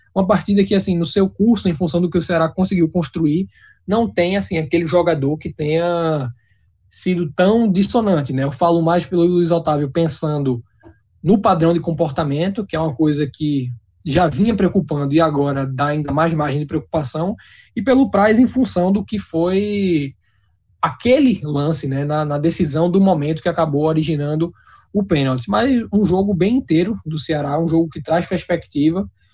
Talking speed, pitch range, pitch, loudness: 175 wpm, 150-185 Hz, 165 Hz, -18 LUFS